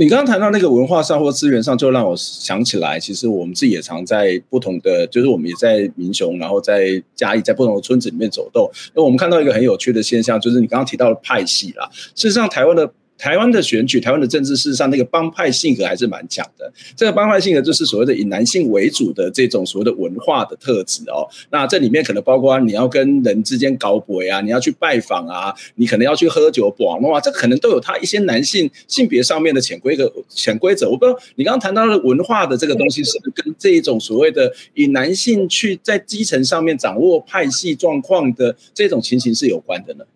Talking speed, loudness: 365 characters per minute, -15 LUFS